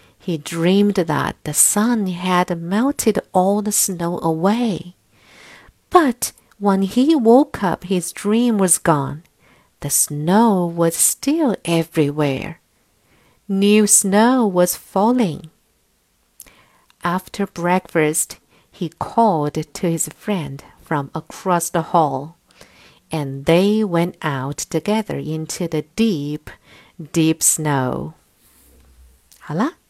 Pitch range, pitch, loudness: 155-205 Hz, 175 Hz, -18 LUFS